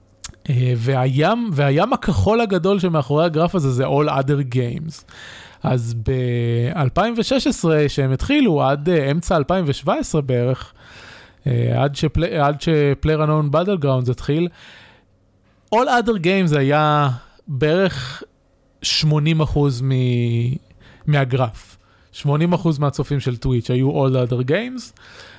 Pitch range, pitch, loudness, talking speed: 130-170 Hz, 145 Hz, -19 LUFS, 100 wpm